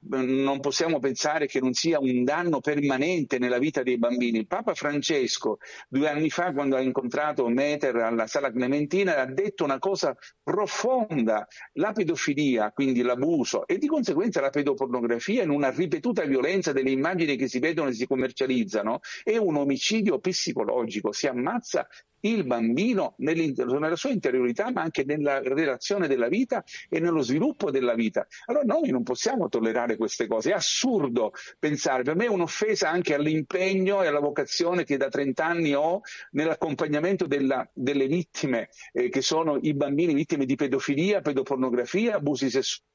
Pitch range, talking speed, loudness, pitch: 135-185 Hz, 155 wpm, -26 LUFS, 145 Hz